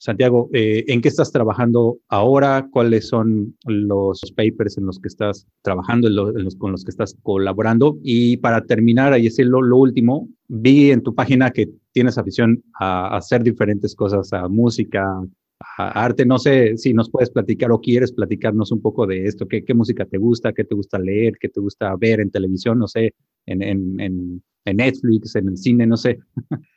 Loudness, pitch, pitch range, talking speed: -18 LUFS, 115 Hz, 100-120 Hz, 200 wpm